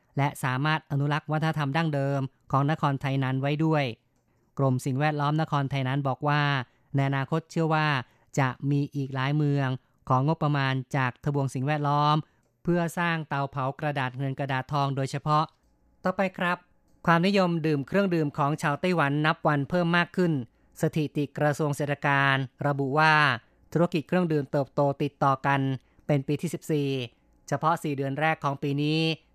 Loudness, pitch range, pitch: -27 LUFS, 135-155 Hz, 145 Hz